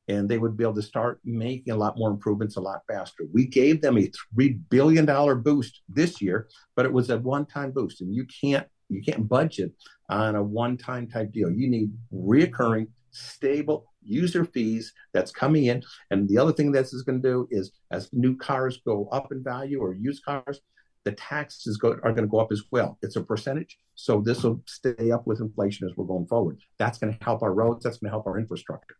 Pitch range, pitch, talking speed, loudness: 110-130 Hz, 120 Hz, 225 wpm, -26 LUFS